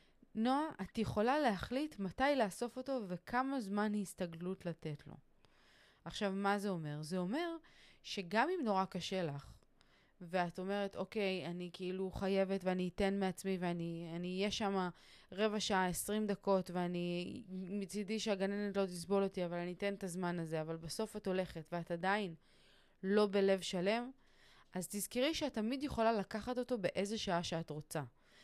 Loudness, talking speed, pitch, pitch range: -39 LUFS, 150 wpm, 195 Hz, 180-210 Hz